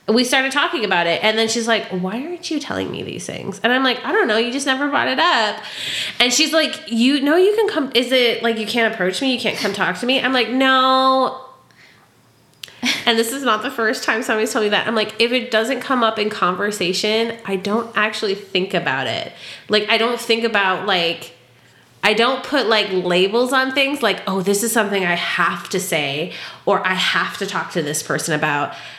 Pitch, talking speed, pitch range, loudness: 225 Hz, 225 wpm, 195-255 Hz, -18 LUFS